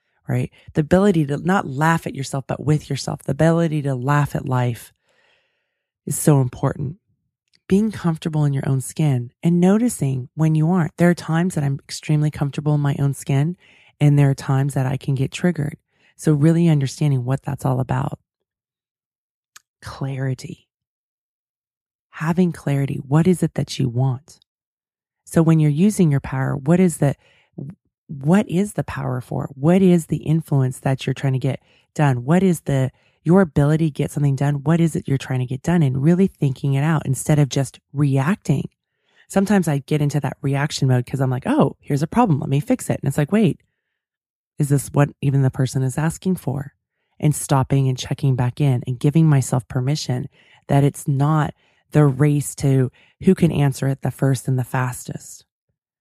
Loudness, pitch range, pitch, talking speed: -20 LUFS, 135-160 Hz, 145 Hz, 185 wpm